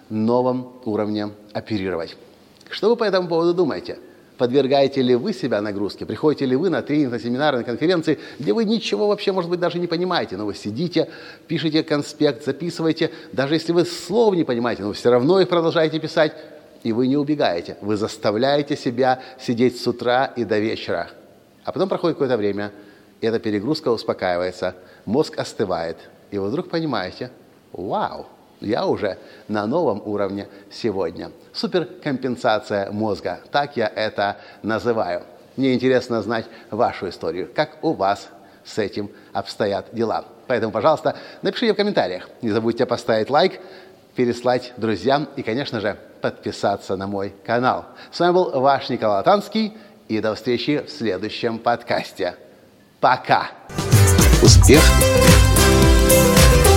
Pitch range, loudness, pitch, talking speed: 105-160 Hz, -20 LUFS, 125 Hz, 145 wpm